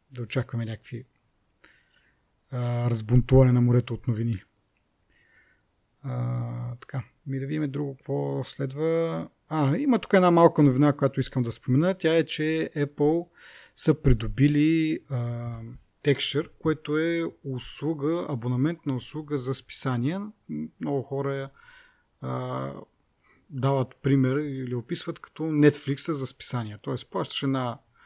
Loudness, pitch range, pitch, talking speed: -26 LUFS, 120-150 Hz, 135 Hz, 120 wpm